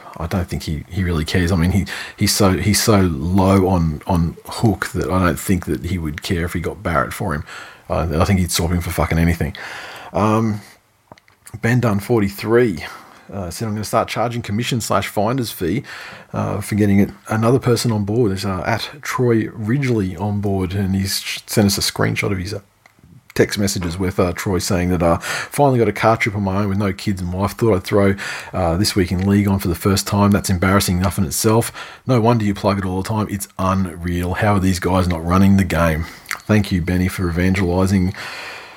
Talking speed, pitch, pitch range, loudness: 220 wpm, 100 Hz, 90-105 Hz, -18 LUFS